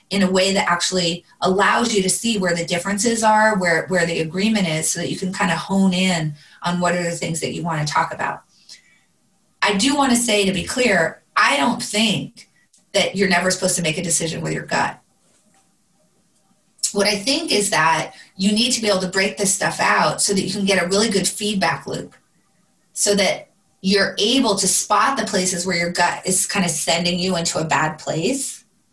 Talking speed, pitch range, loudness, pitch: 215 wpm, 175-205 Hz, -18 LUFS, 190 Hz